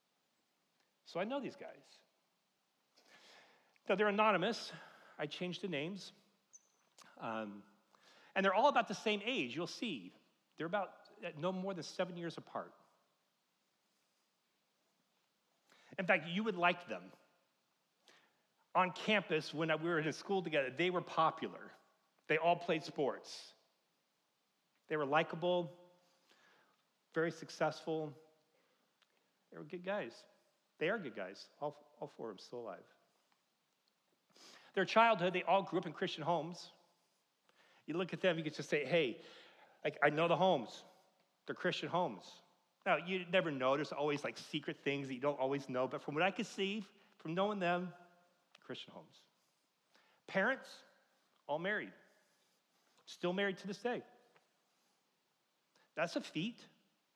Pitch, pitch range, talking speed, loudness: 175 Hz, 155-195 Hz, 140 wpm, -38 LUFS